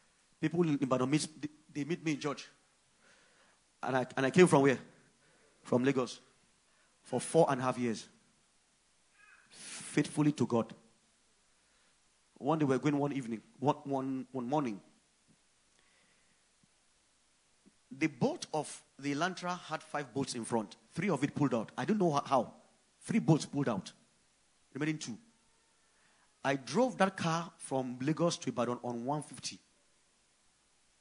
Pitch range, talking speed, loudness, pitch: 130-165 Hz, 145 wpm, -34 LUFS, 145 Hz